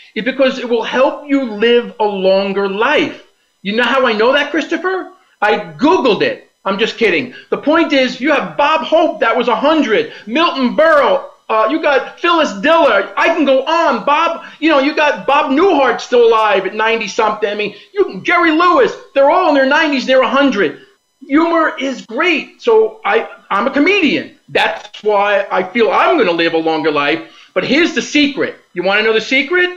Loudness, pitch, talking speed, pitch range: -13 LUFS, 280 Hz, 195 wpm, 225-325 Hz